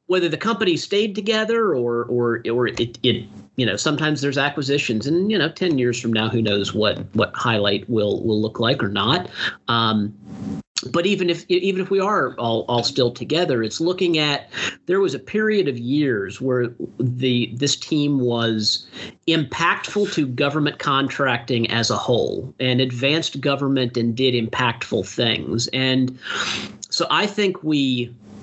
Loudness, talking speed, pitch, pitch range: -21 LUFS, 165 wpm, 130 Hz, 115-155 Hz